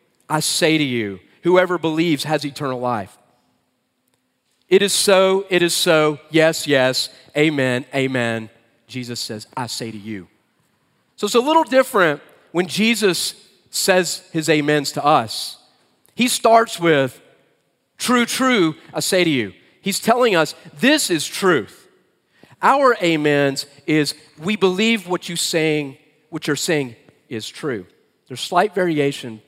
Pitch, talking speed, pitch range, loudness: 155 Hz, 140 wpm, 135-185 Hz, -18 LUFS